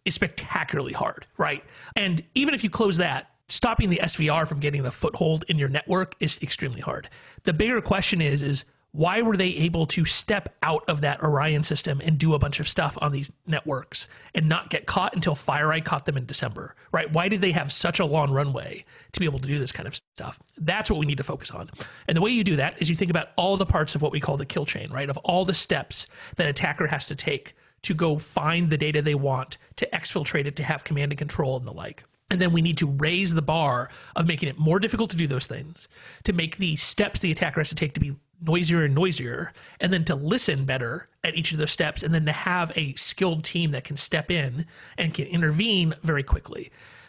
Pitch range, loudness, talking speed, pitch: 145-175 Hz, -25 LUFS, 240 wpm, 160 Hz